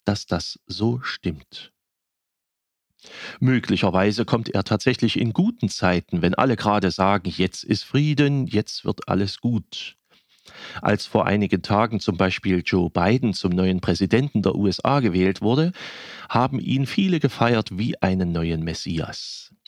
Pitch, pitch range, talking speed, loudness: 105 Hz, 95-120 Hz, 135 wpm, -22 LUFS